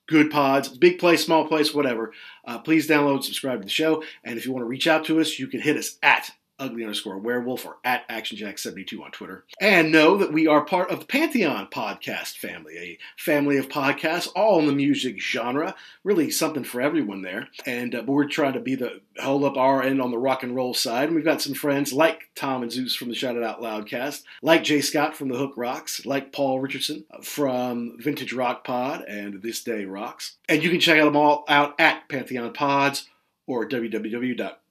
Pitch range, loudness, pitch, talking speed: 125-155 Hz, -23 LUFS, 140 Hz, 215 wpm